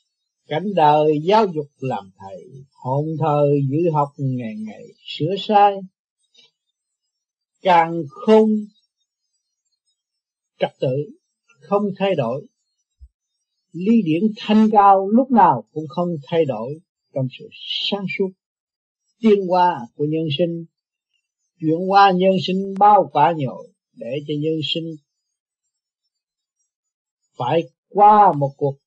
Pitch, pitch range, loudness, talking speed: 175 Hz, 150-205 Hz, -18 LUFS, 115 wpm